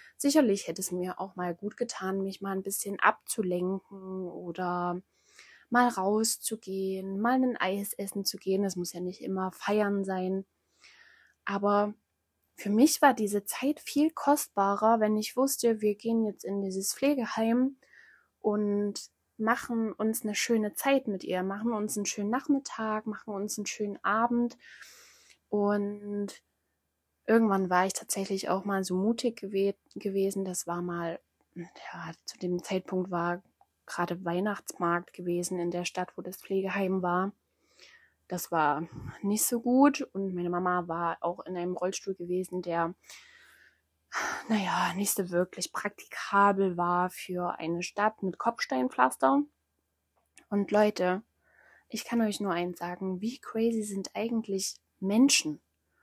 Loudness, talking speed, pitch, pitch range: -30 LUFS, 140 wpm, 195 Hz, 180-215 Hz